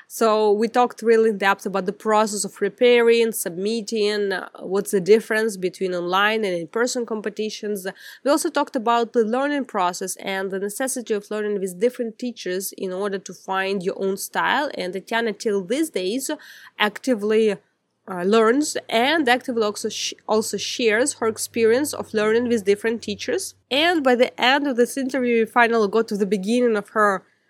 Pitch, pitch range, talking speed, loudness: 220 Hz, 200-245 Hz, 170 wpm, -21 LUFS